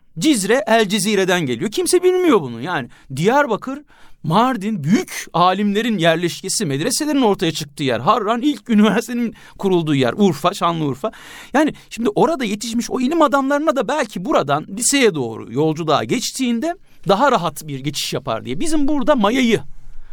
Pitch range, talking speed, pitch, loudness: 160-260 Hz, 140 wpm, 210 Hz, -18 LUFS